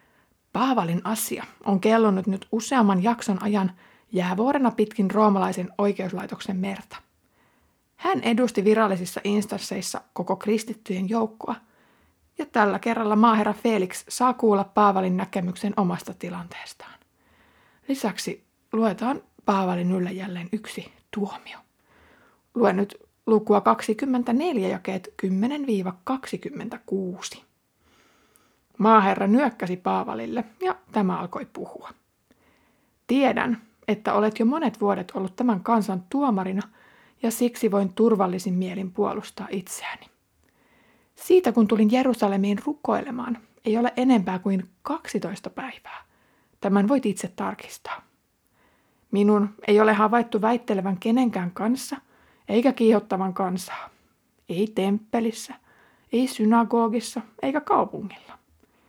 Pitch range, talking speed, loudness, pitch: 195-235 Hz, 100 wpm, -24 LUFS, 215 Hz